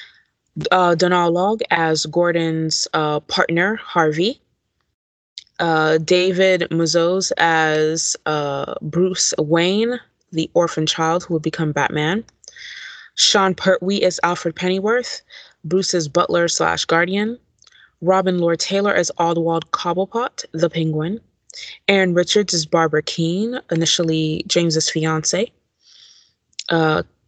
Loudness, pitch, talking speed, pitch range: -18 LUFS, 170 Hz, 105 wpm, 160-185 Hz